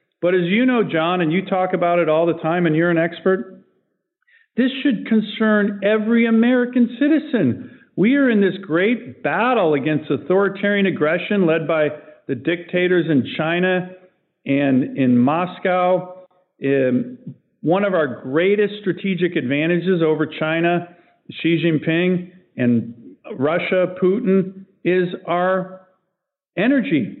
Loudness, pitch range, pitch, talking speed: -19 LUFS, 165-200 Hz, 180 Hz, 130 wpm